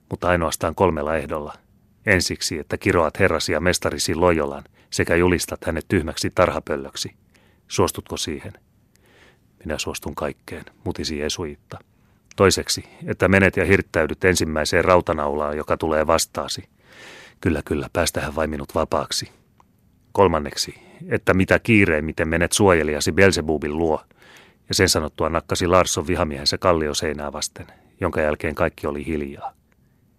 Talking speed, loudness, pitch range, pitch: 120 wpm, -21 LUFS, 75-95 Hz, 85 Hz